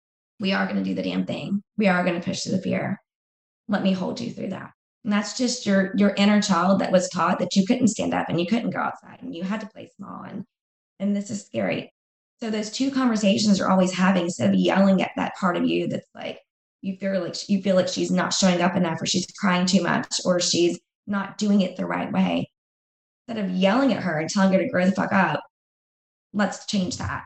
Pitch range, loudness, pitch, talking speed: 180-205 Hz, -23 LUFS, 195 Hz, 245 wpm